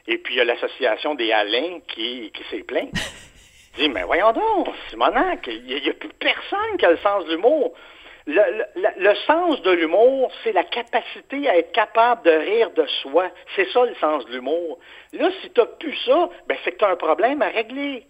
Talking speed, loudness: 220 wpm, -20 LUFS